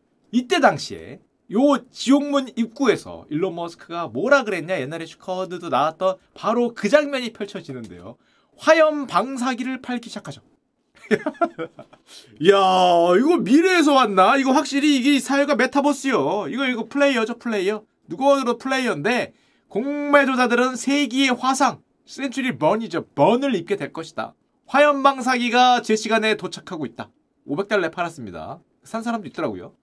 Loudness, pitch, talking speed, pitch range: -20 LUFS, 245 Hz, 330 characters per minute, 195-280 Hz